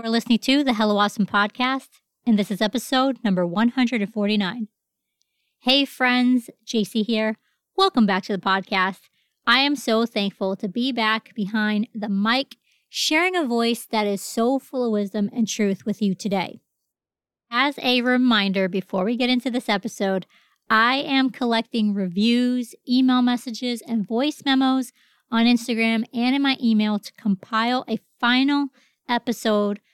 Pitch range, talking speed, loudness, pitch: 210-250 Hz, 150 wpm, -22 LUFS, 230 Hz